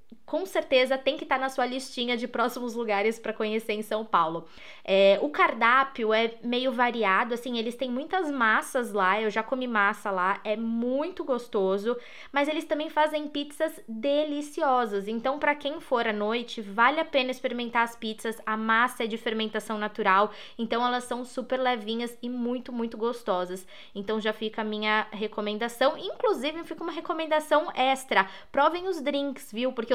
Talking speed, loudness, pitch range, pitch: 170 wpm, -27 LUFS, 220-270 Hz, 240 Hz